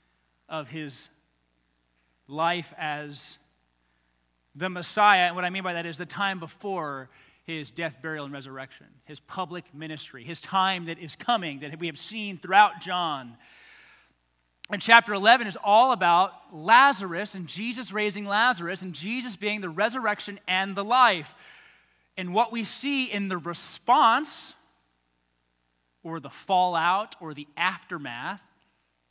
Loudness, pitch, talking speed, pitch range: -25 LUFS, 170 Hz, 140 wpm, 140-200 Hz